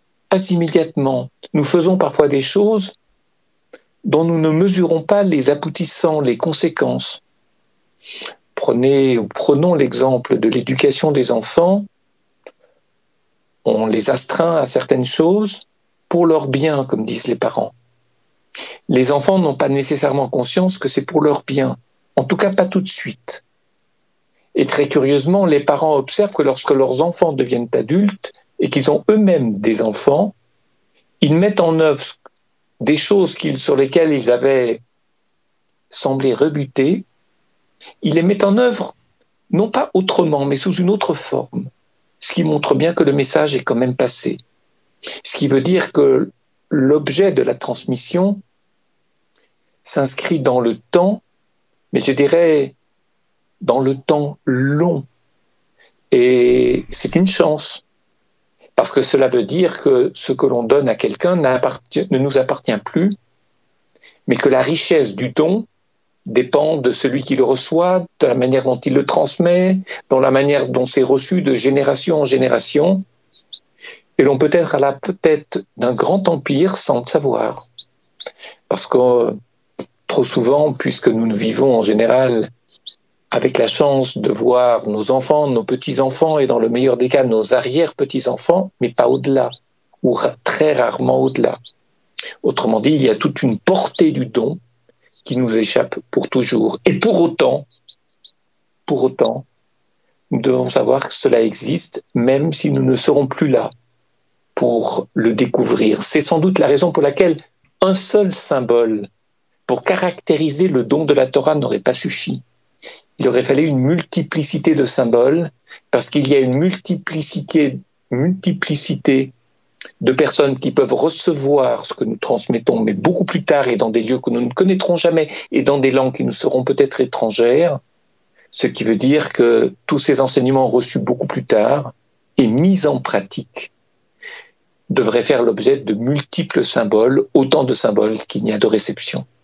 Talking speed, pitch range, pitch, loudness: 155 wpm, 130-180 Hz, 150 Hz, -16 LUFS